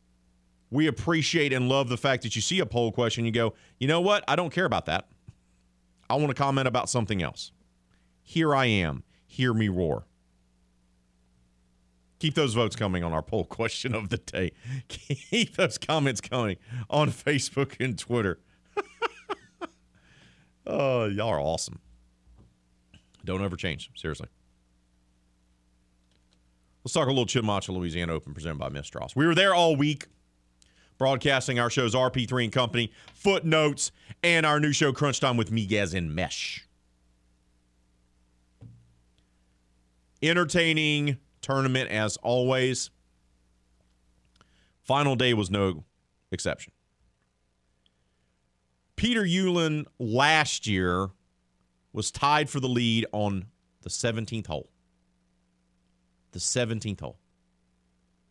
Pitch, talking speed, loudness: 95 Hz, 120 wpm, -27 LUFS